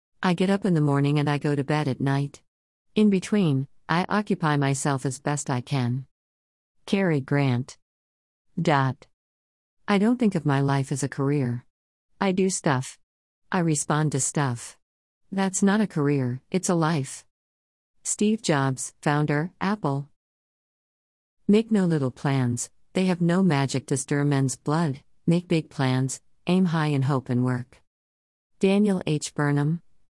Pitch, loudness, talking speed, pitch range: 145 Hz, -25 LUFS, 150 wpm, 125-170 Hz